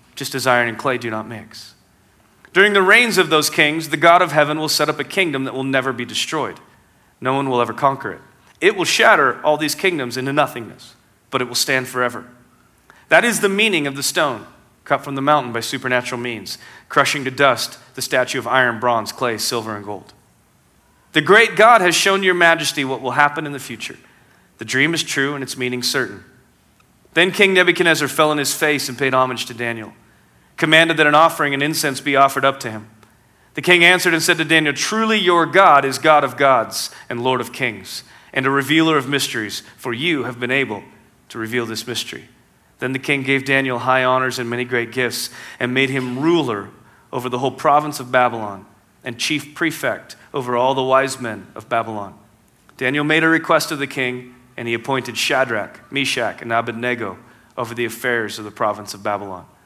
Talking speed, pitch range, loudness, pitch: 205 wpm, 120-150 Hz, -17 LUFS, 130 Hz